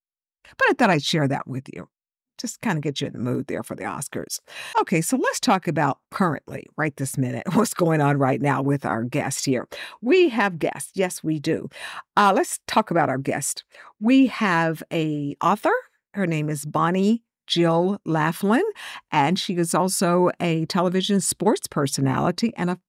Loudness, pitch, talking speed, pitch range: -22 LUFS, 170 Hz, 185 wpm, 150-200 Hz